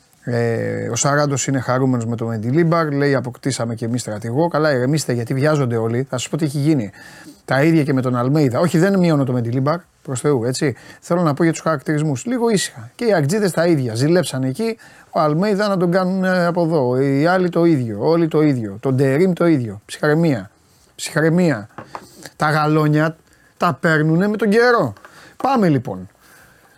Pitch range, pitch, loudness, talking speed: 125-170 Hz, 150 Hz, -18 LUFS, 180 wpm